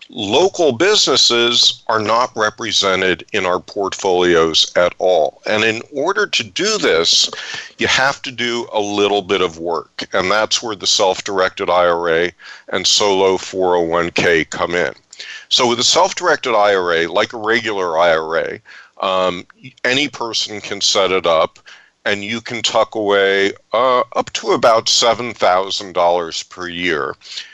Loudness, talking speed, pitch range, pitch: -15 LUFS, 145 wpm, 90-115 Hz, 100 Hz